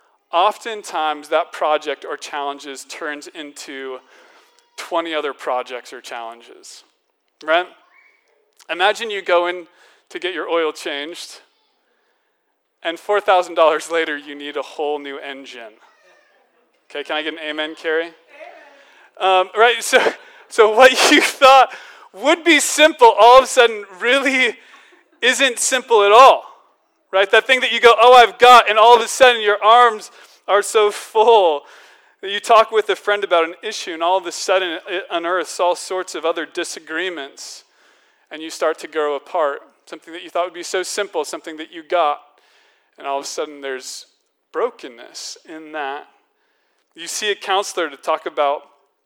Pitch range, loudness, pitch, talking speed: 160-255 Hz, -16 LUFS, 190 Hz, 160 wpm